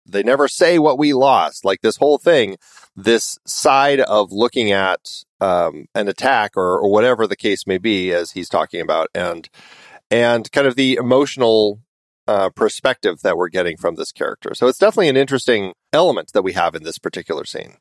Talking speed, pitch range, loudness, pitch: 190 wpm, 110-140 Hz, -17 LUFS, 125 Hz